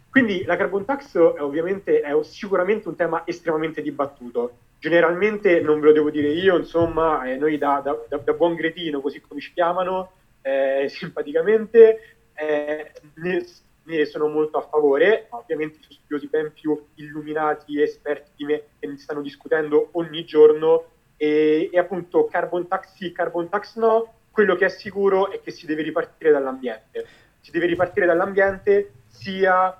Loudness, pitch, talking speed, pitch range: -21 LUFS, 165 Hz, 165 wpm, 150-185 Hz